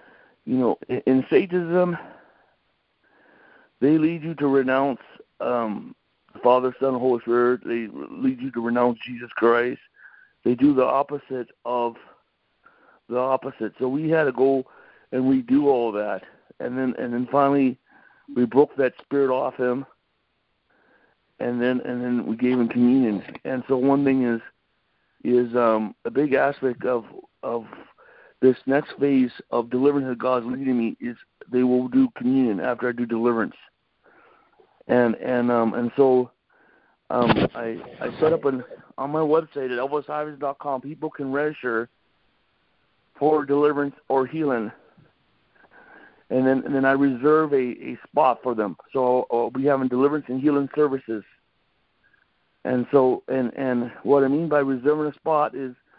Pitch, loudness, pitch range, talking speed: 130 Hz, -23 LUFS, 125-145 Hz, 150 wpm